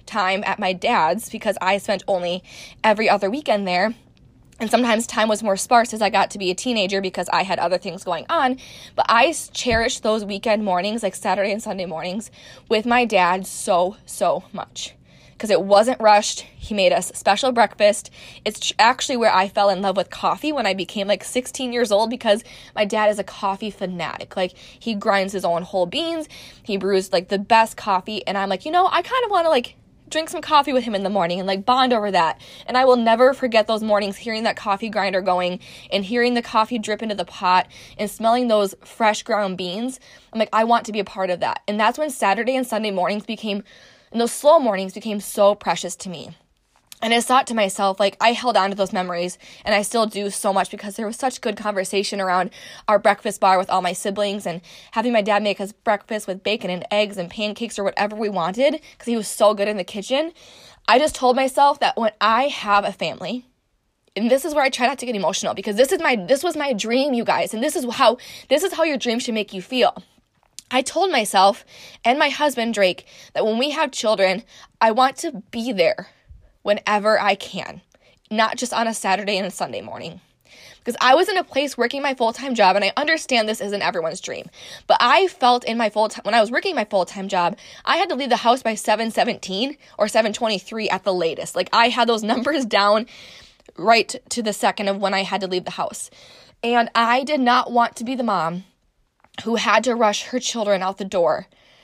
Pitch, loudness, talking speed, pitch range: 215 Hz, -20 LUFS, 225 wpm, 195-240 Hz